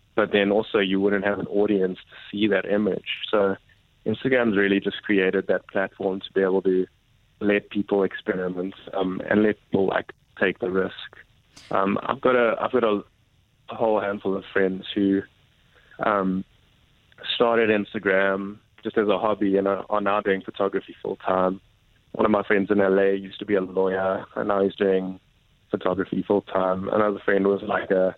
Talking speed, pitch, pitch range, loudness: 175 wpm, 100 Hz, 95-105 Hz, -24 LUFS